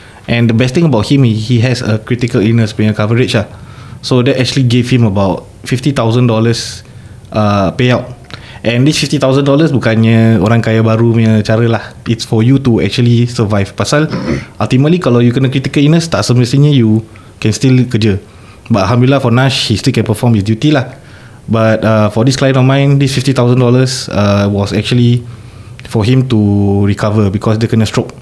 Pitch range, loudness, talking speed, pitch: 110-130 Hz, -11 LUFS, 175 wpm, 115 Hz